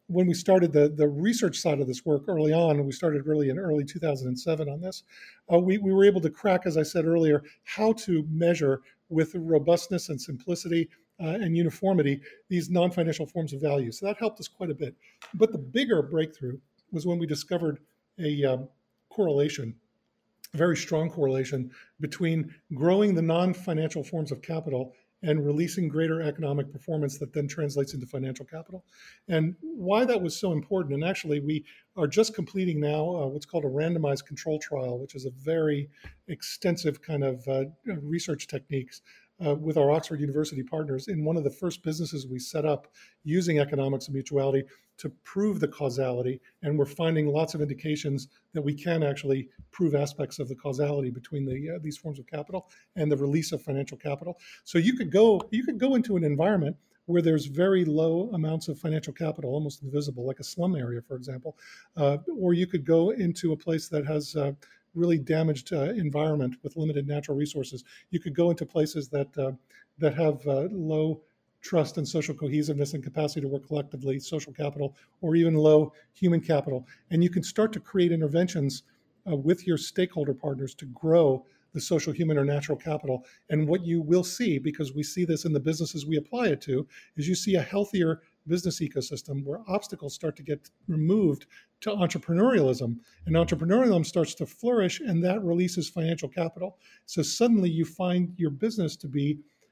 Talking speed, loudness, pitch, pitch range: 185 wpm, -28 LUFS, 155 Hz, 145-175 Hz